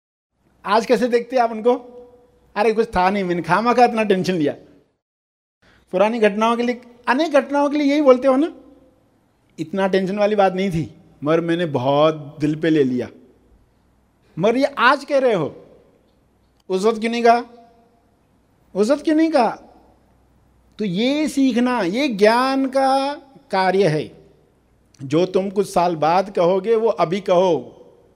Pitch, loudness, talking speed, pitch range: 220 Hz, -18 LUFS, 150 wpm, 180-250 Hz